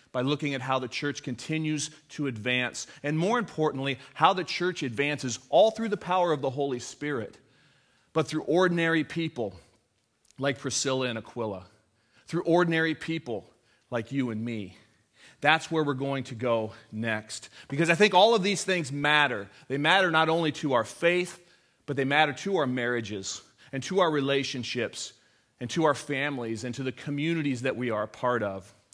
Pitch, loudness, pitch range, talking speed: 140 Hz, -28 LUFS, 120-160 Hz, 175 wpm